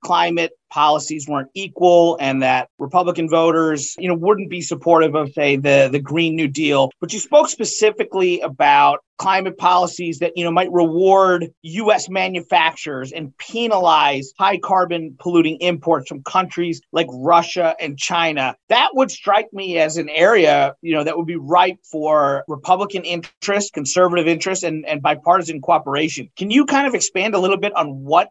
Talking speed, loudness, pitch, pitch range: 165 wpm, -17 LUFS, 170 Hz, 155-185 Hz